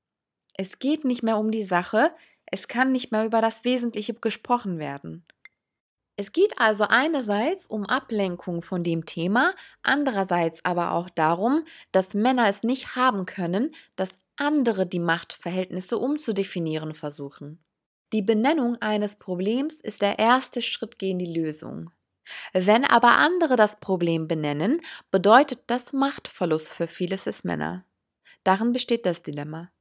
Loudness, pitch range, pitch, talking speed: -24 LUFS, 175-250 Hz, 210 Hz, 140 wpm